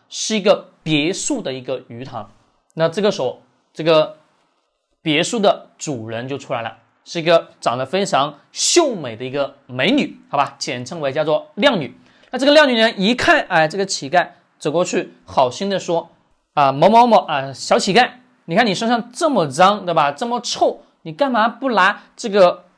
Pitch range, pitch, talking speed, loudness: 145-235 Hz, 175 Hz, 265 characters per minute, -17 LUFS